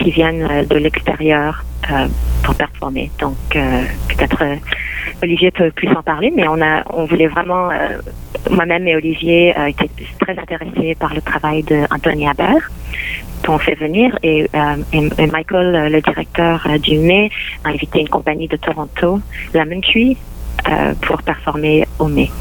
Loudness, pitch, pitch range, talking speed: -15 LUFS, 160 Hz, 155-175 Hz, 165 wpm